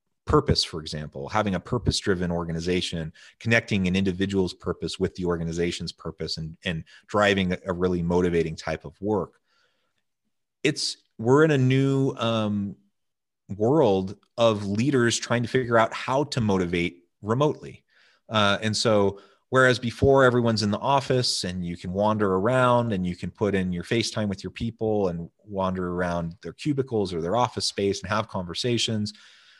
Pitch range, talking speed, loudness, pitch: 90-115 Hz, 160 wpm, -25 LUFS, 100 Hz